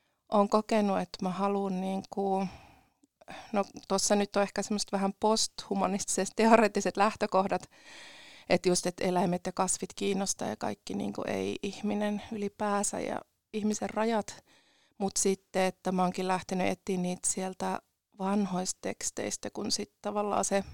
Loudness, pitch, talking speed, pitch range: -31 LUFS, 200 Hz, 130 wpm, 190-215 Hz